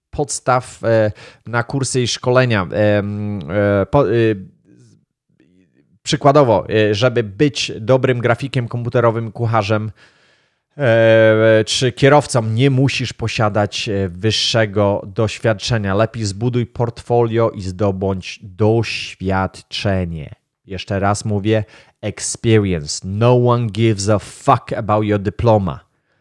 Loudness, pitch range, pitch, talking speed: -16 LUFS, 105-120 Hz, 110 Hz, 85 wpm